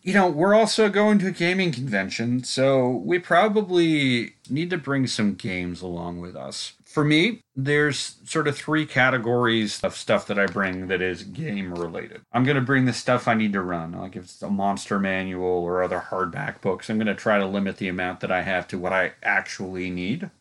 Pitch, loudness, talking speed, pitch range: 120 Hz, -23 LUFS, 210 wpm, 95-150 Hz